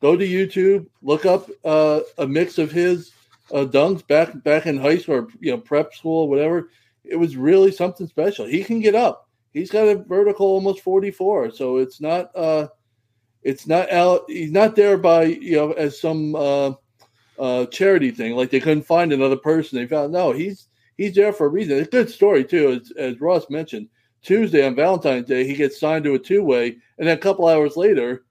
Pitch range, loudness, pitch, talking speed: 140-195 Hz, -19 LUFS, 160 Hz, 210 wpm